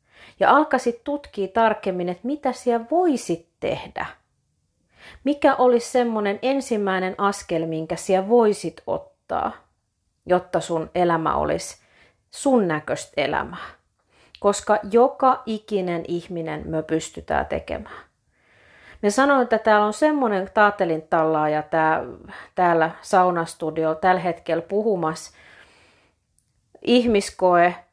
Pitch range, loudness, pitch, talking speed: 170-235 Hz, -22 LUFS, 195 Hz, 100 wpm